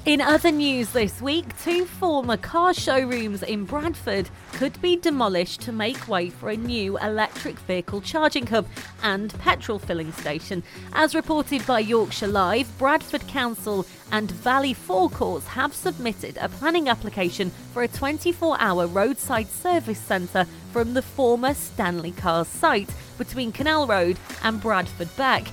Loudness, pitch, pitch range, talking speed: -24 LUFS, 230 Hz, 195-295 Hz, 145 wpm